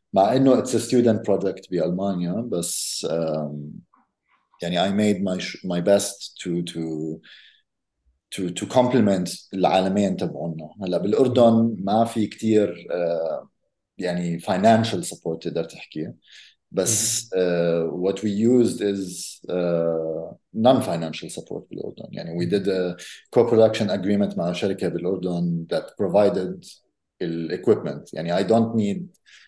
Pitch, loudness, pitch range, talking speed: 95 Hz, -23 LUFS, 85-105 Hz, 120 wpm